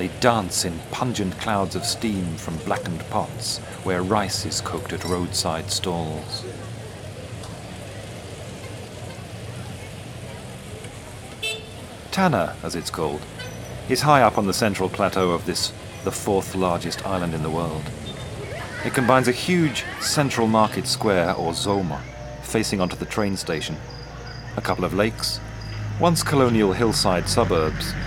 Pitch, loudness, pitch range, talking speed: 105 Hz, -23 LUFS, 95-115 Hz, 125 wpm